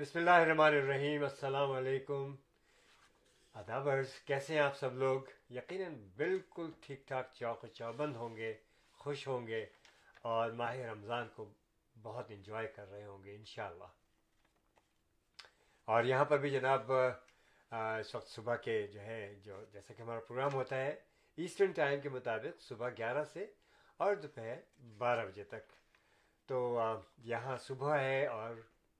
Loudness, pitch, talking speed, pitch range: -37 LUFS, 130 Hz, 145 wpm, 115-145 Hz